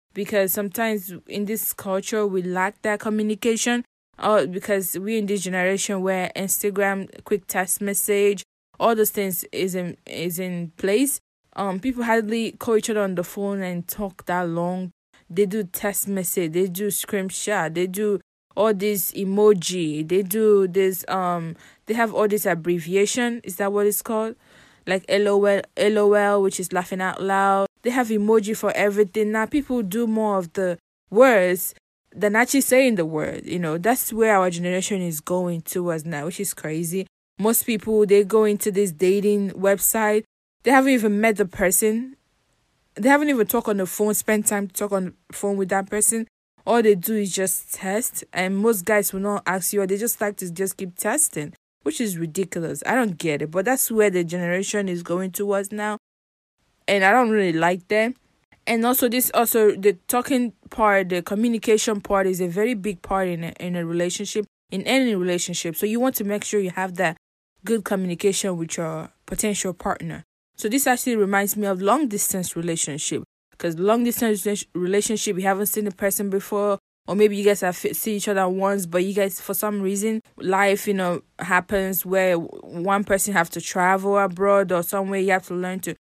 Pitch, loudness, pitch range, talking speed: 200 Hz, -22 LUFS, 185-215 Hz, 185 wpm